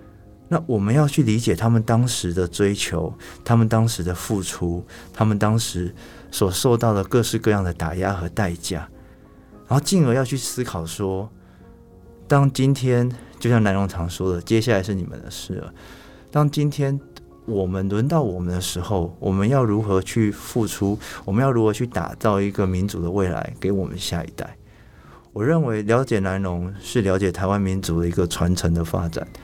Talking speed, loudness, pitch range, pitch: 265 characters per minute, -22 LUFS, 90-115 Hz, 100 Hz